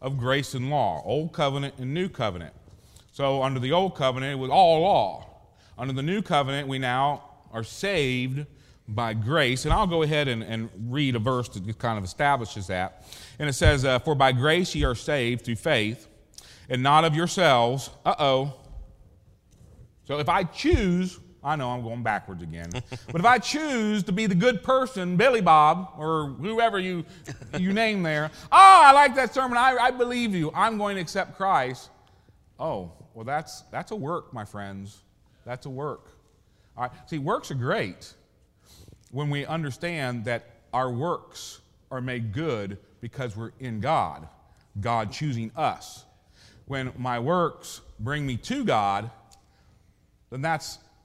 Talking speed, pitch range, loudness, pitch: 170 wpm, 115-160 Hz, -24 LUFS, 130 Hz